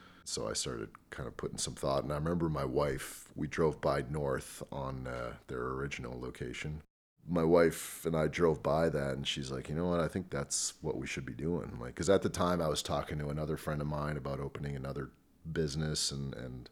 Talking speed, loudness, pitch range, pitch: 225 wpm, -35 LUFS, 70-80 Hz, 75 Hz